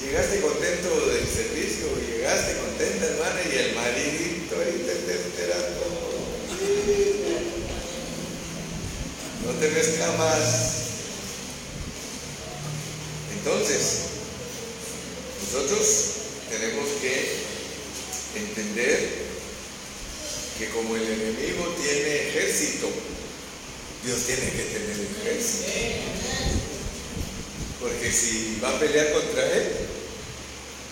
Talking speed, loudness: 75 wpm, -26 LUFS